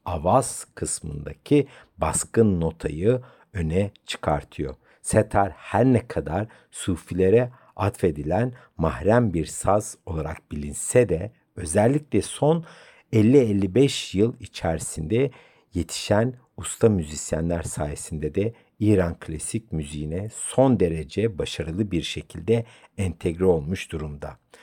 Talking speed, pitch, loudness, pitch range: 95 wpm, 100 Hz, -24 LUFS, 80-115 Hz